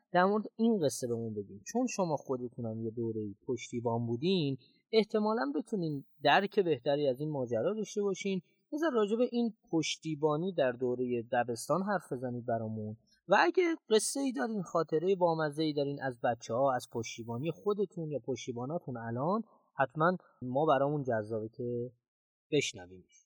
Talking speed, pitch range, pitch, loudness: 150 wpm, 120-200 Hz, 150 Hz, -33 LUFS